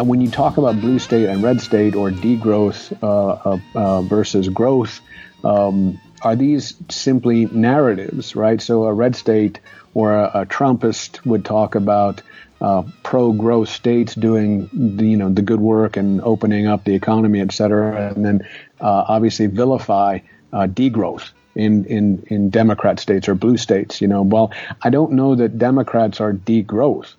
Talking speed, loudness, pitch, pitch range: 170 wpm, -17 LUFS, 110 Hz, 105-115 Hz